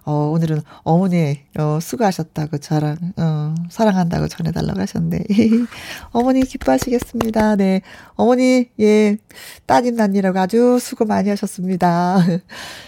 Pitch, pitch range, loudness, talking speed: 190 Hz, 165-225 Hz, -18 LUFS, 300 characters per minute